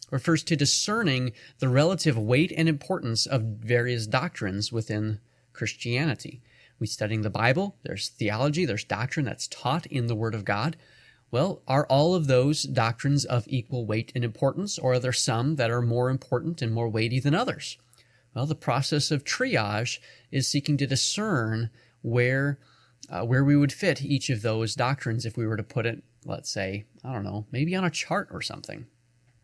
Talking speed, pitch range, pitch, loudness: 180 wpm, 115-145 Hz, 125 Hz, -27 LUFS